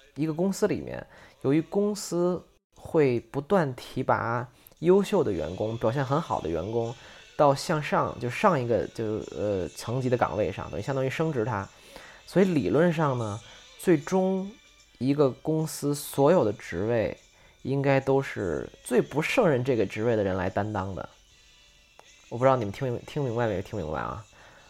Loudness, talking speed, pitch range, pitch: -27 LUFS, 245 characters per minute, 110-155 Hz, 130 Hz